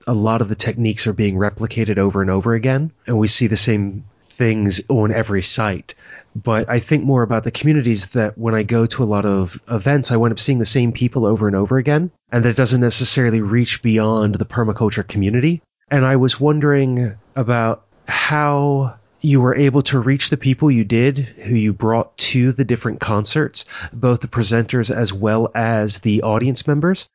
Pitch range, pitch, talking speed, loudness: 110-130 Hz, 115 Hz, 195 wpm, -17 LUFS